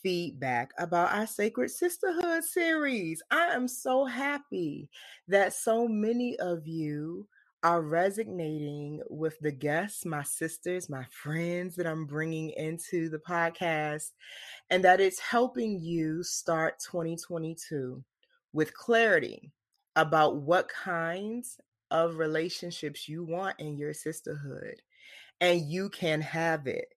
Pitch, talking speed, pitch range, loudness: 170 Hz, 120 wpm, 160-210 Hz, -30 LUFS